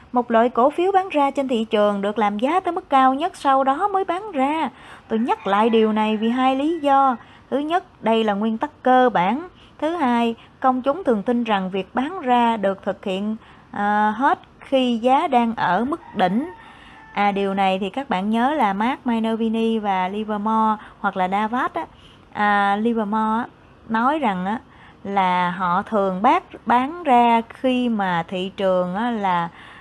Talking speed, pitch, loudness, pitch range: 175 wpm, 230 Hz, -20 LUFS, 205-270 Hz